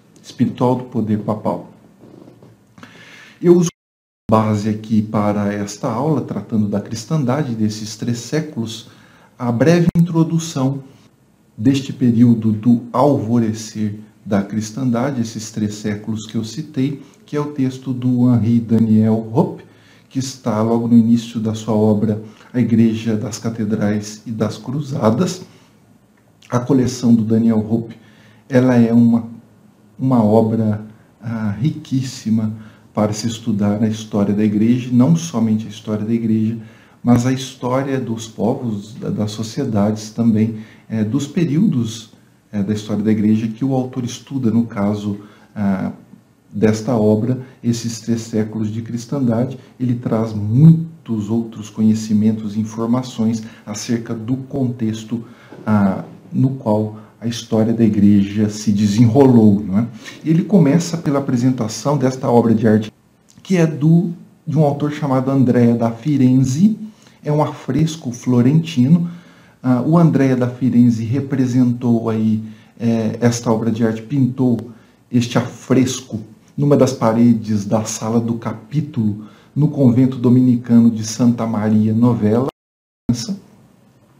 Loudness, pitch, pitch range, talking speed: -17 LUFS, 115 Hz, 110-130 Hz, 130 wpm